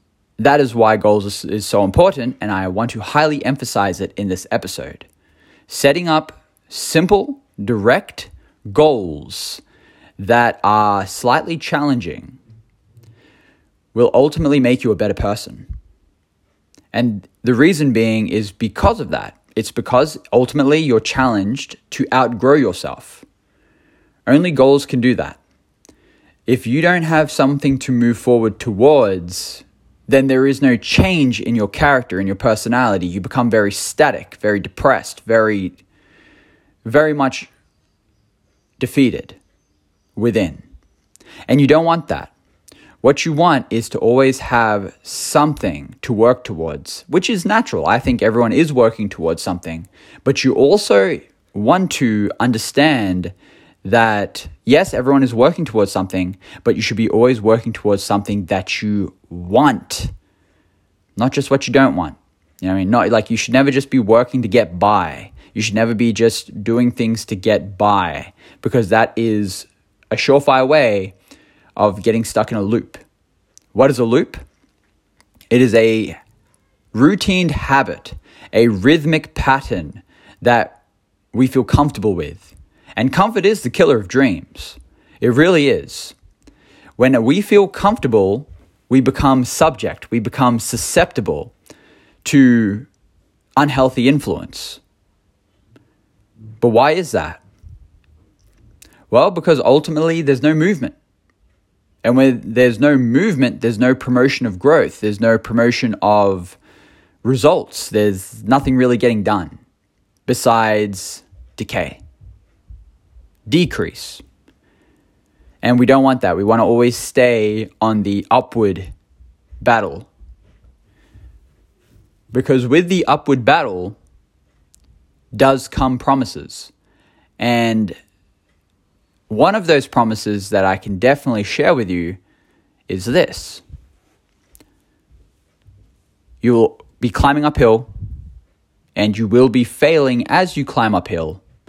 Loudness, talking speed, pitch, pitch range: -15 LUFS, 130 wpm, 110 Hz, 100-130 Hz